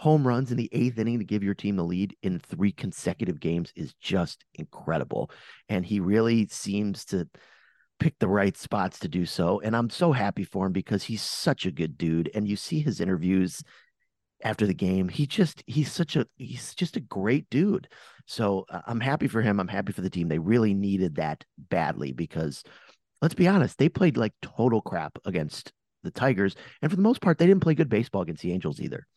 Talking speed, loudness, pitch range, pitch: 210 wpm, -27 LUFS, 95-130 Hz, 105 Hz